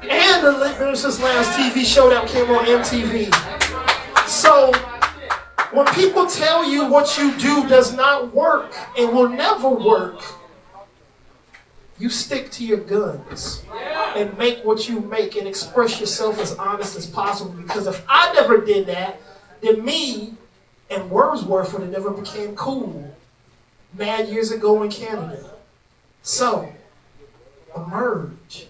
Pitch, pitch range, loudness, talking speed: 230 Hz, 205-275 Hz, -18 LUFS, 130 wpm